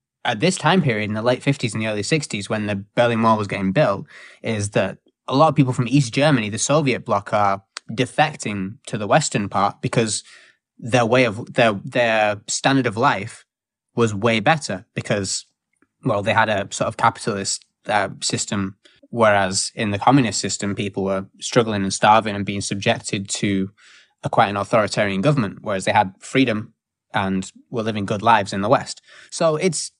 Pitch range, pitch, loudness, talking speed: 100-130 Hz, 110 Hz, -20 LUFS, 185 wpm